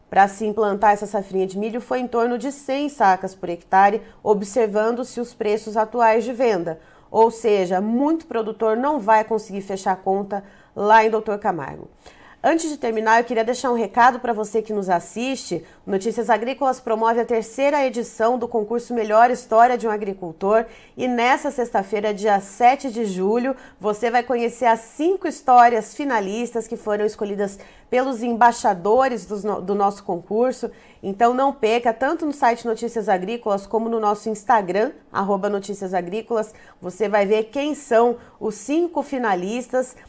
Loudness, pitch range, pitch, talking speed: -21 LUFS, 205-245 Hz, 225 Hz, 160 wpm